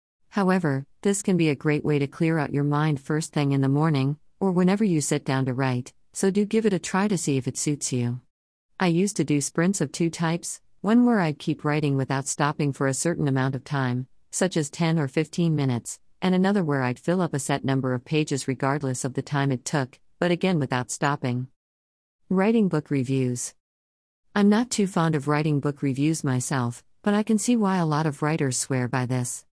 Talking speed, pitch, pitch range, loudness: 220 wpm, 150 Hz, 135-170 Hz, -25 LUFS